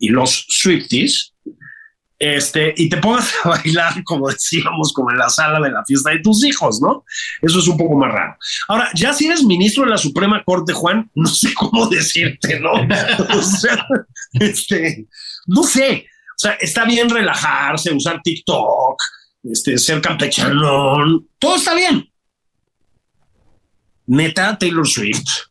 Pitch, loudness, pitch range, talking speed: 180 Hz, -15 LUFS, 155-235 Hz, 150 wpm